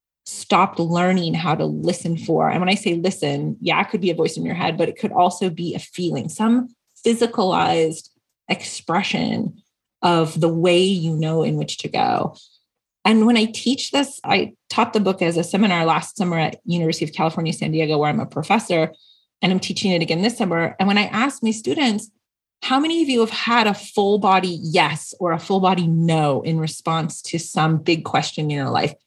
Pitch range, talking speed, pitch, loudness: 165-210 Hz, 205 wpm, 180 Hz, -20 LUFS